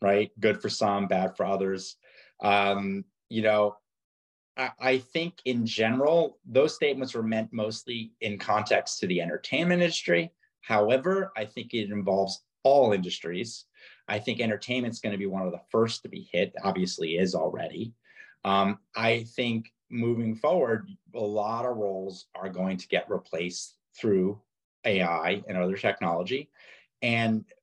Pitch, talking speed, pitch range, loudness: 105 Hz, 150 wpm, 95-115 Hz, -28 LUFS